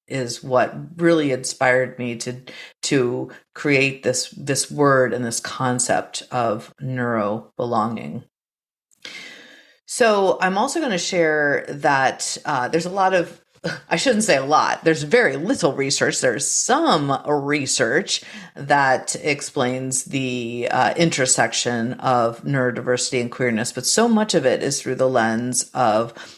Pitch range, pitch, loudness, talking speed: 125-170 Hz, 135 Hz, -20 LUFS, 135 wpm